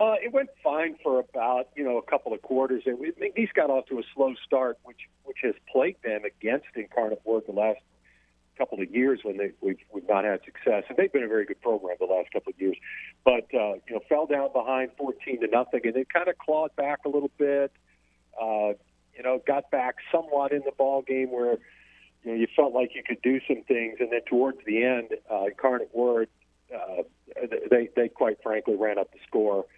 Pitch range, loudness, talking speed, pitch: 115-155 Hz, -27 LUFS, 225 wpm, 130 Hz